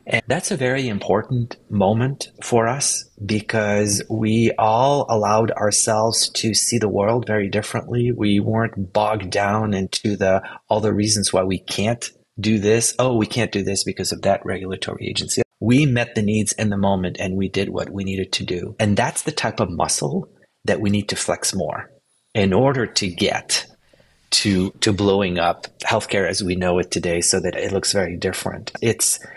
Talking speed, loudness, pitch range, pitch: 185 wpm, -20 LUFS, 95-115 Hz, 105 Hz